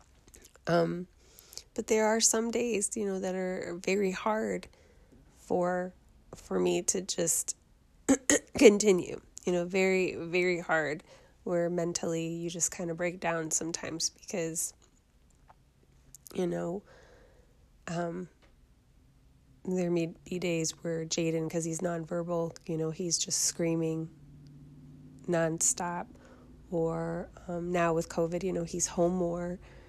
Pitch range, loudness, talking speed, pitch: 165-185 Hz, -31 LUFS, 120 wpm, 175 Hz